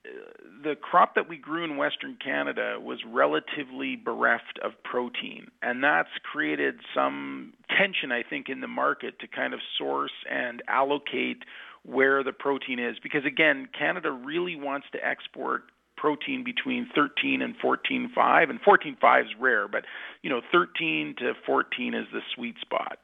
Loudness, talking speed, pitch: -27 LUFS, 155 wpm, 155 Hz